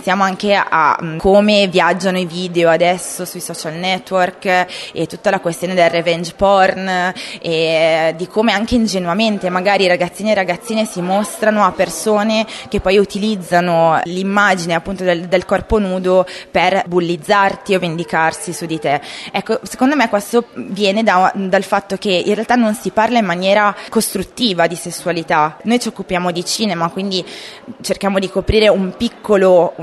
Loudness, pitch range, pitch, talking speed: -15 LUFS, 175-205 Hz, 190 Hz, 155 wpm